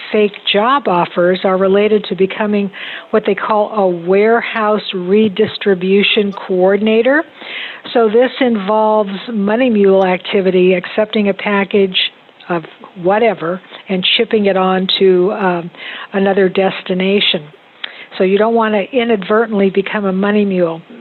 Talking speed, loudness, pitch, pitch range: 125 wpm, -13 LUFS, 200 Hz, 190-215 Hz